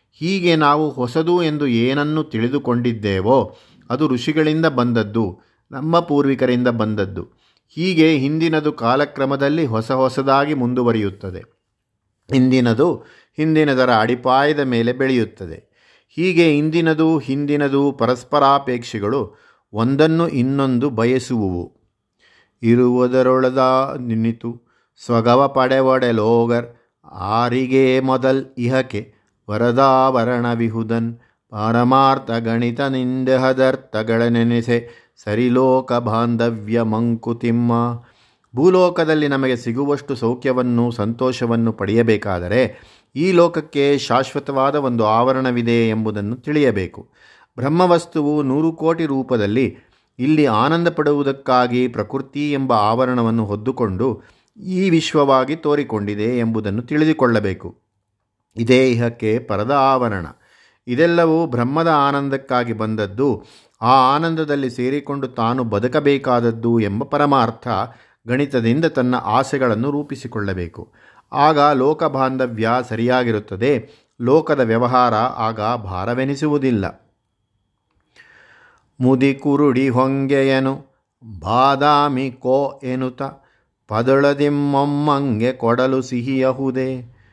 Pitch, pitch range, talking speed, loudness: 125 Hz, 115-140 Hz, 75 wpm, -17 LUFS